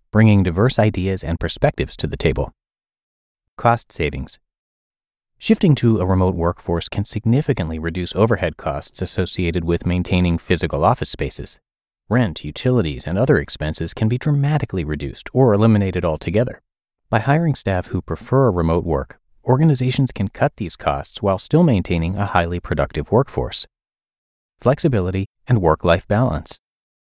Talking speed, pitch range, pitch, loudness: 140 wpm, 85-120 Hz, 95 Hz, -19 LUFS